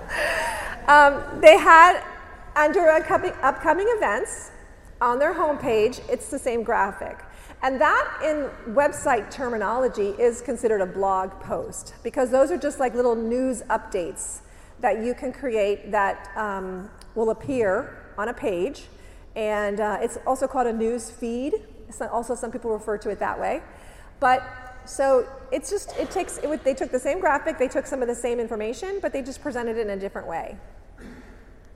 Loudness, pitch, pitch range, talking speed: -23 LUFS, 255 Hz, 220-290 Hz, 170 wpm